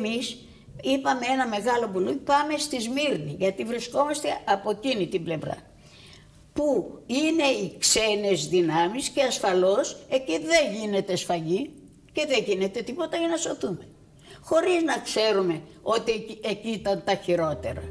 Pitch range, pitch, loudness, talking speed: 190-275 Hz, 220 Hz, -25 LUFS, 135 wpm